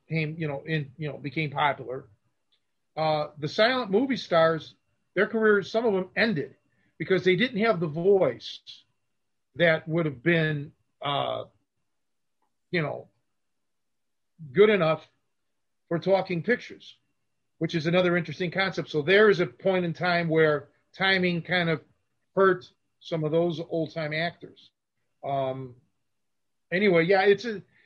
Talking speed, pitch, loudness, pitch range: 140 wpm, 170 Hz, -25 LUFS, 155-190 Hz